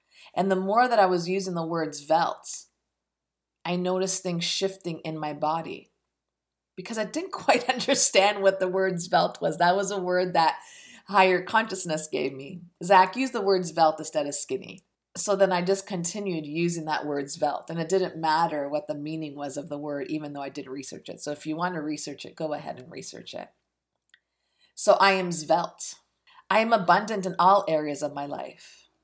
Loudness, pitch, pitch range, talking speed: -25 LUFS, 175 Hz, 150-195 Hz, 195 wpm